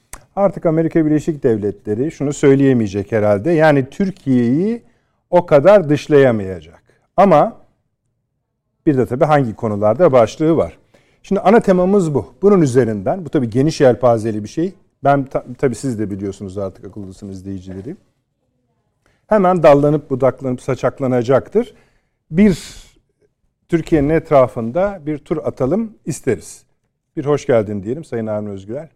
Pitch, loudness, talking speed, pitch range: 135 Hz, -16 LUFS, 120 wpm, 115-160 Hz